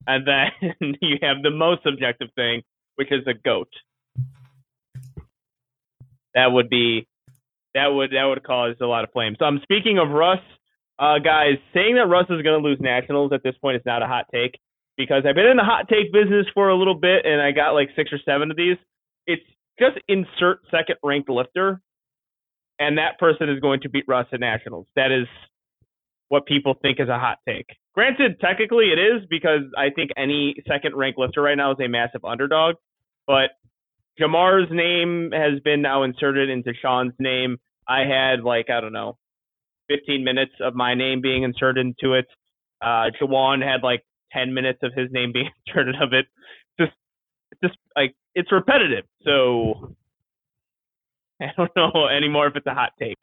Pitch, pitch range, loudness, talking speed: 140 Hz, 130-155 Hz, -20 LUFS, 185 wpm